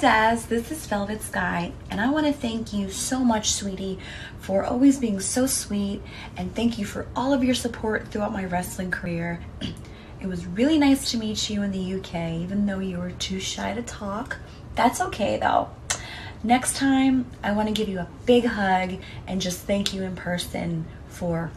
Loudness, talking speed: -25 LUFS, 190 wpm